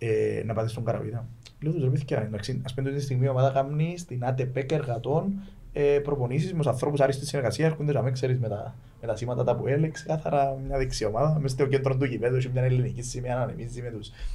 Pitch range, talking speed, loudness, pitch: 120-145 Hz, 220 wpm, -27 LUFS, 130 Hz